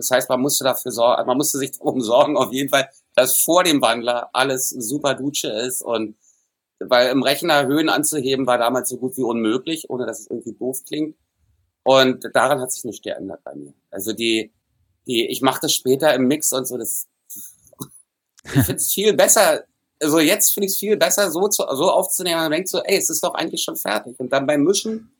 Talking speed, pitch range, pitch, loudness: 215 wpm, 120-150 Hz, 130 Hz, -19 LUFS